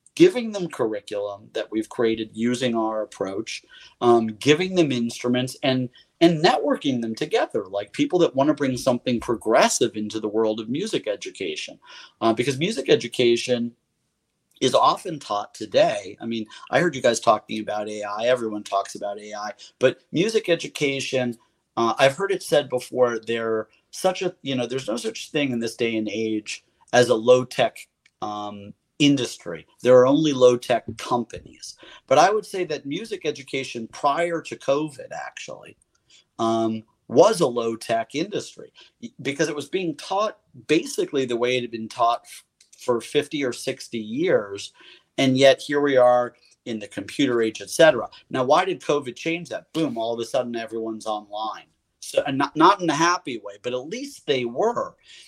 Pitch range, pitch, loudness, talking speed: 115-155 Hz, 125 Hz, -23 LUFS, 170 wpm